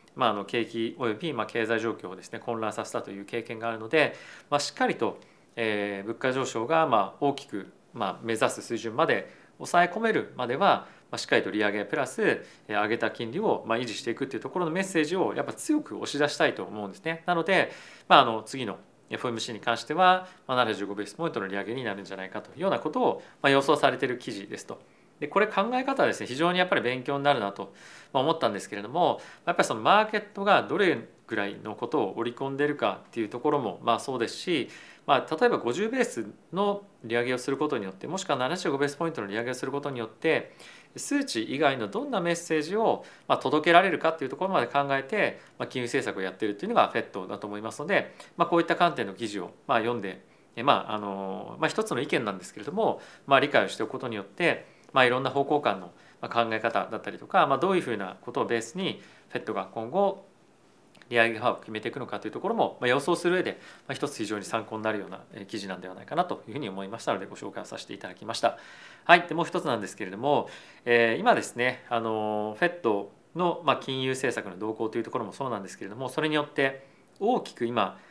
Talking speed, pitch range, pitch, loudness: 465 characters per minute, 110-170 Hz, 130 Hz, -28 LUFS